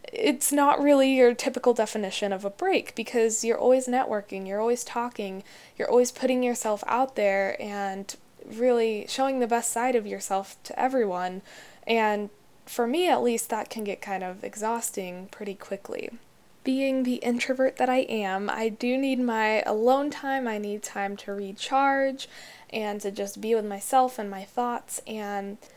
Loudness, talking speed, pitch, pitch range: -26 LUFS, 170 wpm, 230 Hz, 200-255 Hz